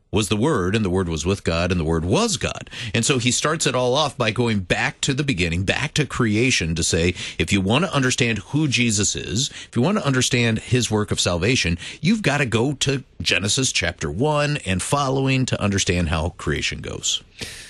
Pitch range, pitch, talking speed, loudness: 95-135 Hz, 115 Hz, 215 wpm, -20 LUFS